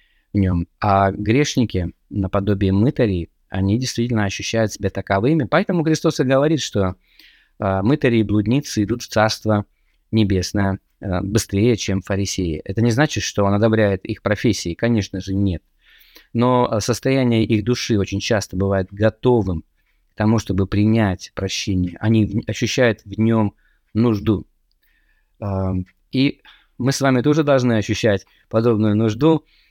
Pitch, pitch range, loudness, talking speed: 110 Hz, 95-120 Hz, -19 LUFS, 125 wpm